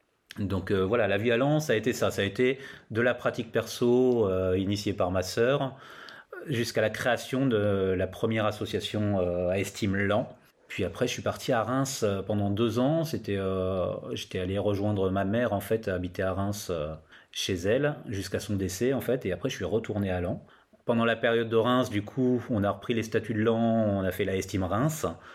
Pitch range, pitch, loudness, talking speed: 95-120 Hz, 105 Hz, -28 LUFS, 220 wpm